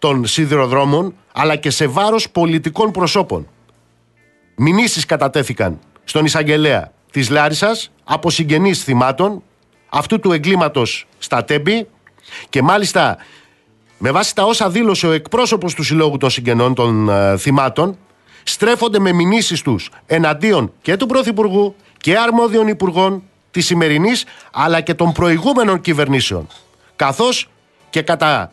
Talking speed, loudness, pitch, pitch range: 125 wpm, -15 LUFS, 165 Hz, 140-205 Hz